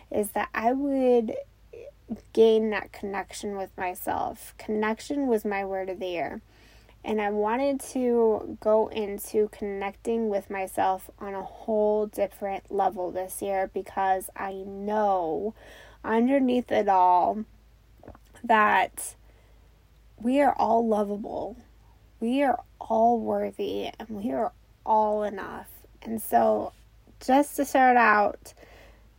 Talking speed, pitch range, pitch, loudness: 120 wpm, 195-230 Hz, 210 Hz, -26 LUFS